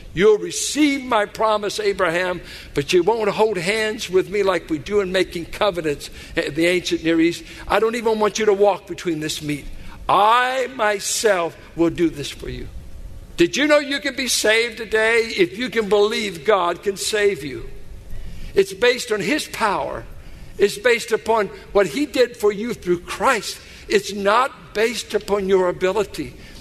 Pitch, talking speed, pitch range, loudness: 205 Hz, 175 wpm, 175-225 Hz, -20 LUFS